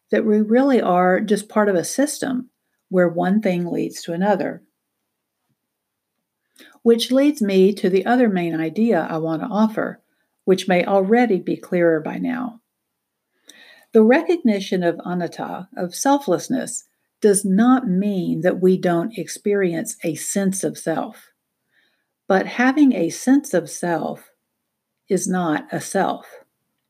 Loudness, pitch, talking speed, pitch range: -19 LUFS, 200 Hz, 135 wpm, 180-245 Hz